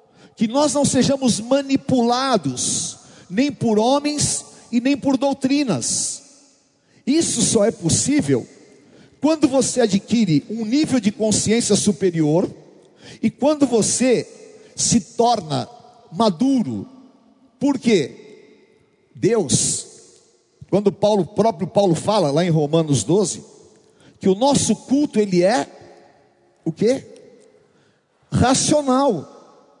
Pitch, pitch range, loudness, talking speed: 235 Hz, 205-275 Hz, -19 LUFS, 100 wpm